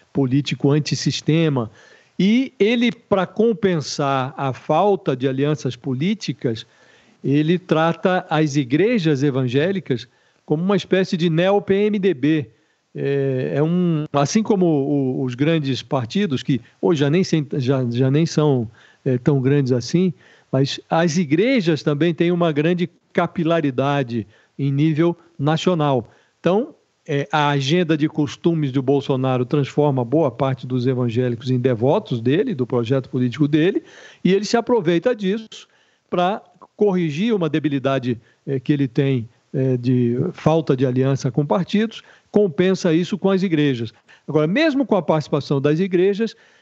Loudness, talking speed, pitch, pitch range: -20 LUFS, 135 wpm, 150 Hz, 135-180 Hz